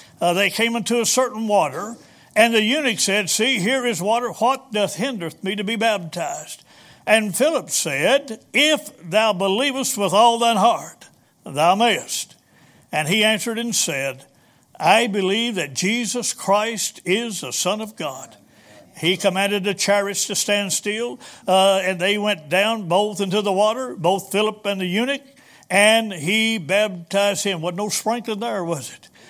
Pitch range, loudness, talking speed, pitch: 195-230 Hz, -20 LUFS, 165 wpm, 210 Hz